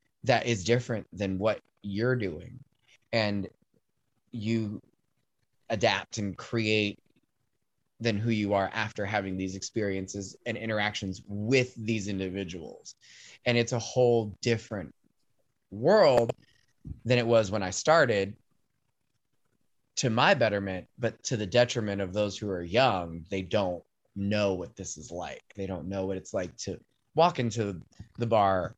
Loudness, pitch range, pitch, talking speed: -29 LUFS, 95-115 Hz, 105 Hz, 140 wpm